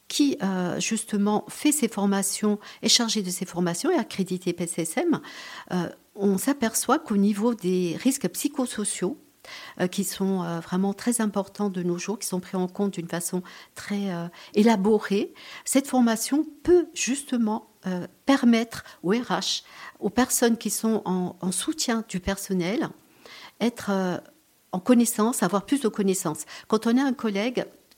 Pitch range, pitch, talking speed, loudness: 185-240 Hz, 205 Hz, 155 wpm, -25 LUFS